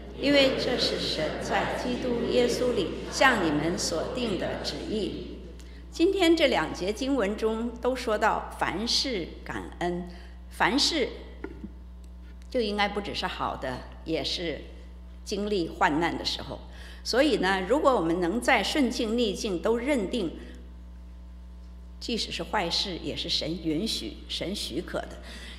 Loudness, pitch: -27 LUFS, 175 Hz